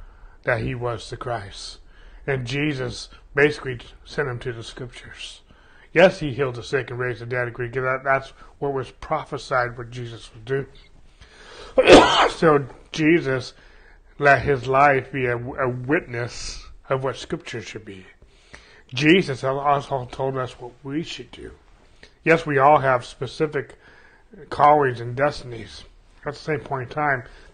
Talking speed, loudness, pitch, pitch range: 155 wpm, -21 LUFS, 130 Hz, 120-145 Hz